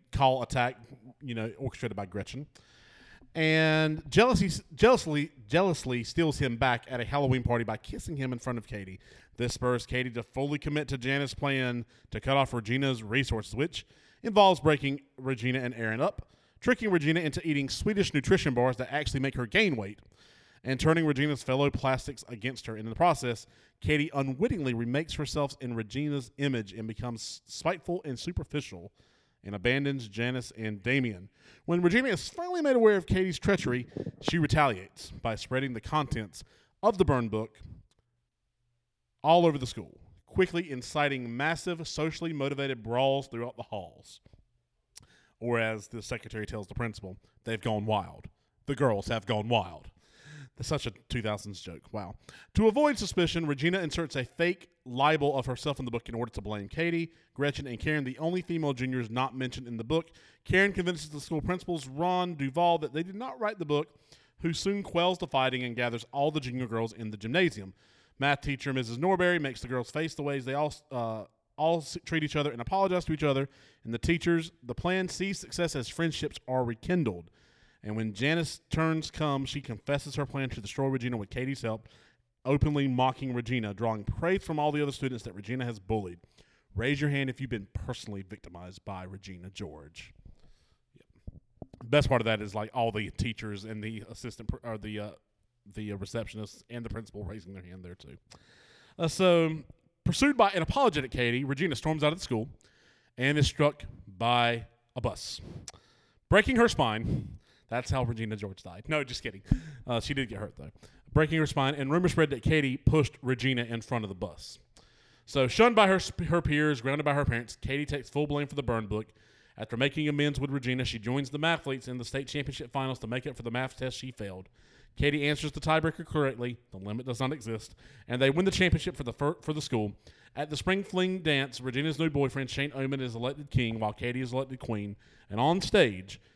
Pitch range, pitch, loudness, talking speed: 115-150 Hz, 130 Hz, -30 LUFS, 190 wpm